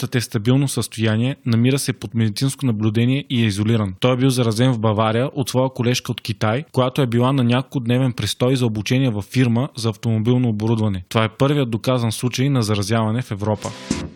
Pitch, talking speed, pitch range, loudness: 120 Hz, 190 wpm, 110-130 Hz, -19 LUFS